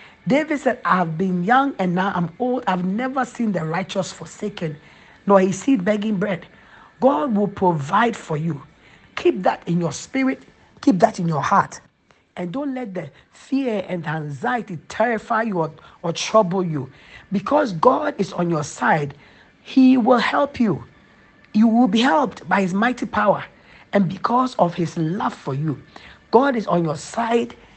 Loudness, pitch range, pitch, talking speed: -20 LUFS, 170-240 Hz, 200 Hz, 170 wpm